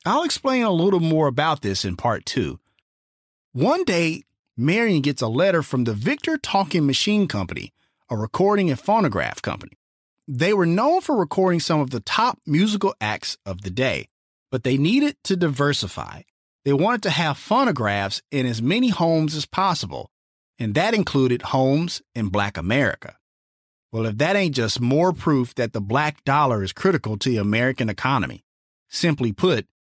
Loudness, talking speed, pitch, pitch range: -21 LUFS, 165 wpm, 140 Hz, 110-175 Hz